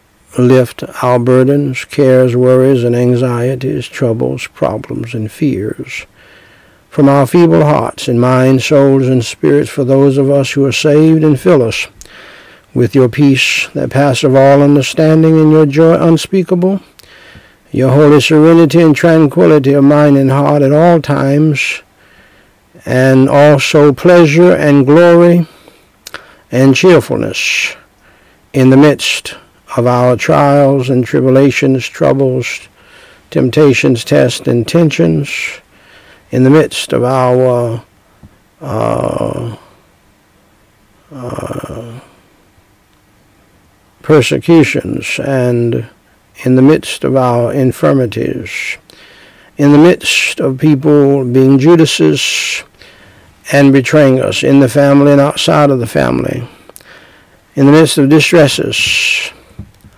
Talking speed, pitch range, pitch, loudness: 110 wpm, 120-150 Hz, 135 Hz, -9 LUFS